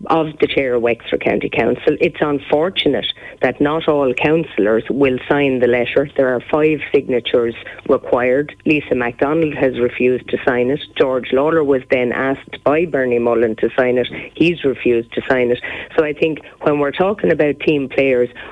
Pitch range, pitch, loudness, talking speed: 125-150 Hz, 135 Hz, -16 LUFS, 175 wpm